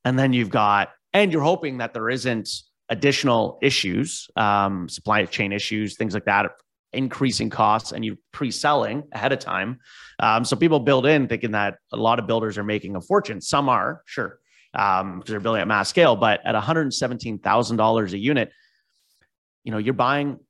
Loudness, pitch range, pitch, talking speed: -22 LUFS, 105-130 Hz, 115 Hz, 180 wpm